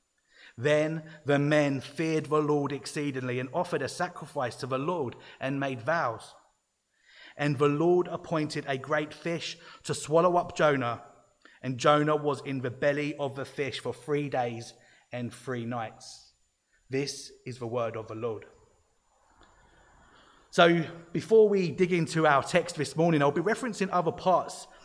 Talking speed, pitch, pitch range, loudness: 155 wpm, 150 Hz, 135-165 Hz, -28 LUFS